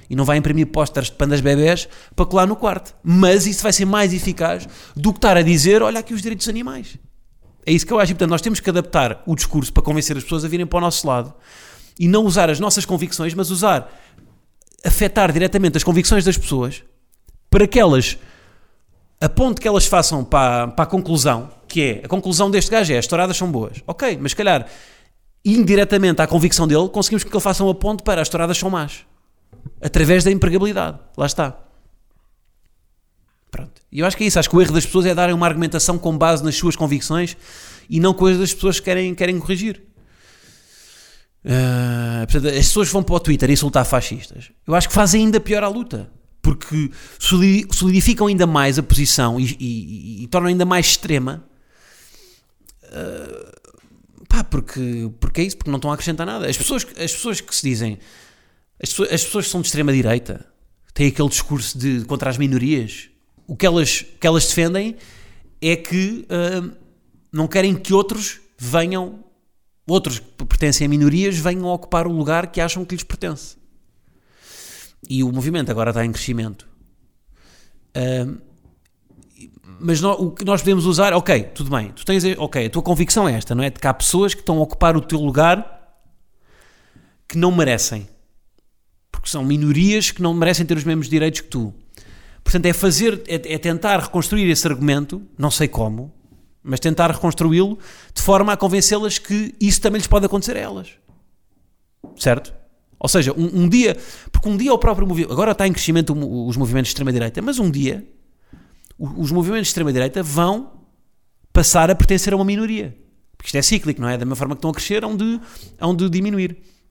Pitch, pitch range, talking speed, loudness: 170 Hz, 140-190 Hz, 190 wpm, -18 LUFS